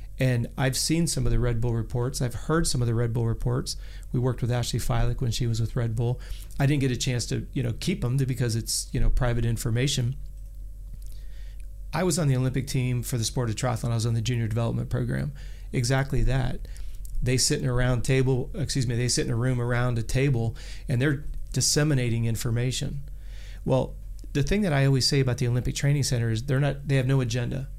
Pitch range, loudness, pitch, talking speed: 115-135 Hz, -26 LUFS, 125 Hz, 220 wpm